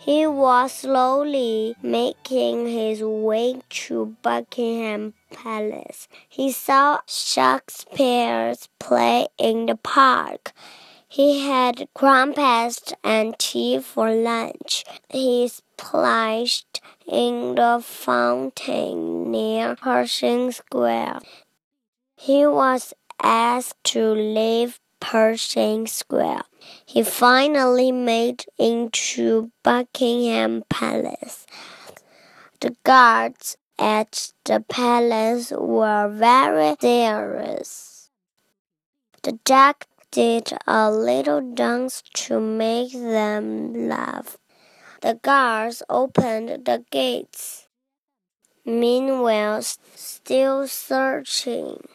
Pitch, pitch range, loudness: 230 Hz, 175-255 Hz, -20 LUFS